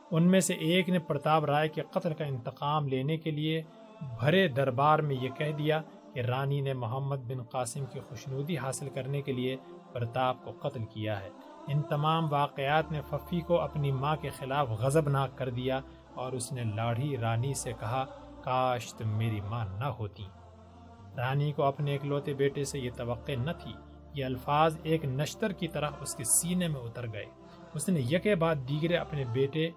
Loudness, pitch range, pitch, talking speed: -31 LUFS, 125-155 Hz, 140 Hz, 190 wpm